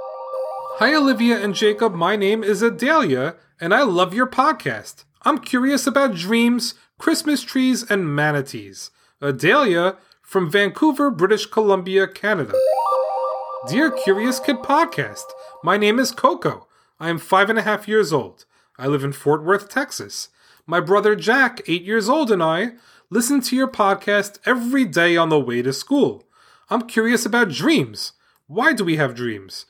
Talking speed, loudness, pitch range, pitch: 155 wpm, -19 LUFS, 165-255 Hz, 210 Hz